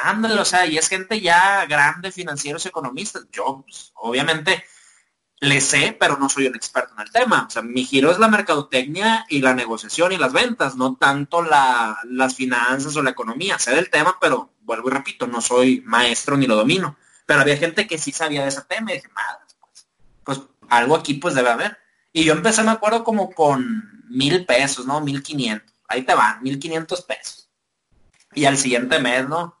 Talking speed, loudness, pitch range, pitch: 200 wpm, -19 LUFS, 130-180 Hz, 145 Hz